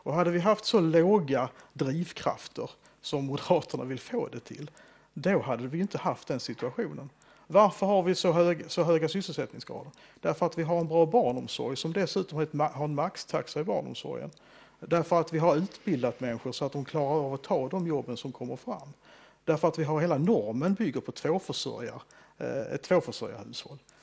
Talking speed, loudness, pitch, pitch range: 180 wpm, -29 LUFS, 165 Hz, 145-180 Hz